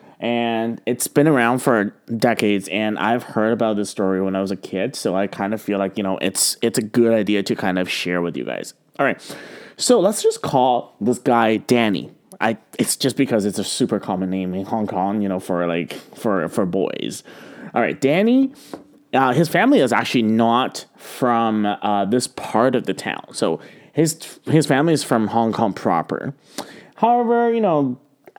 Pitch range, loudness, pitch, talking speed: 100-135 Hz, -20 LUFS, 115 Hz, 195 wpm